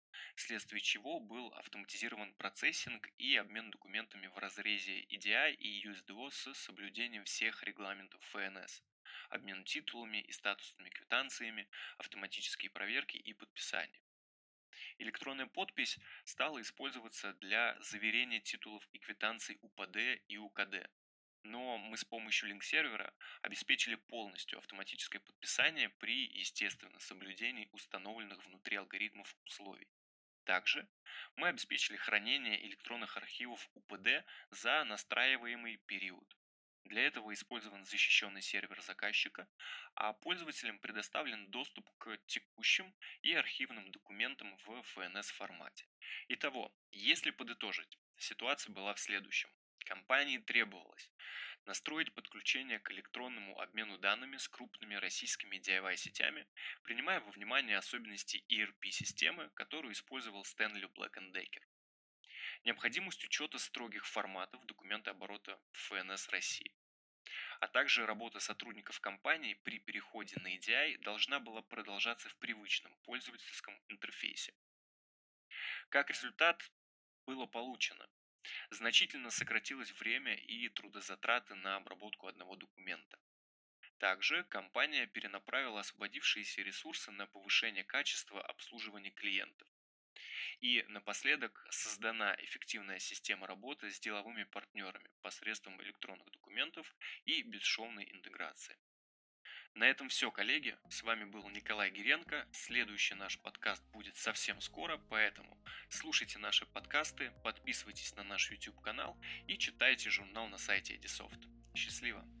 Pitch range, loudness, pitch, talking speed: 95-115 Hz, -39 LUFS, 105 Hz, 110 wpm